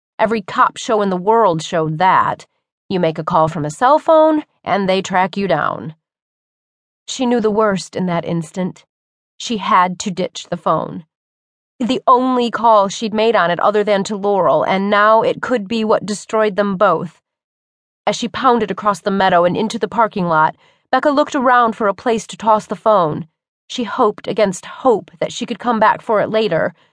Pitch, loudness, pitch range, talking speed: 205 Hz, -16 LUFS, 175-225 Hz, 195 wpm